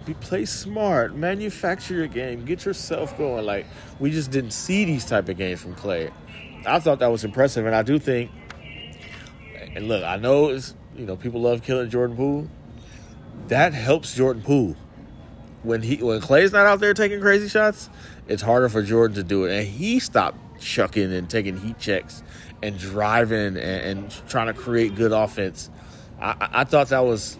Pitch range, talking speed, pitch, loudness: 105-145 Hz, 185 wpm, 120 Hz, -22 LUFS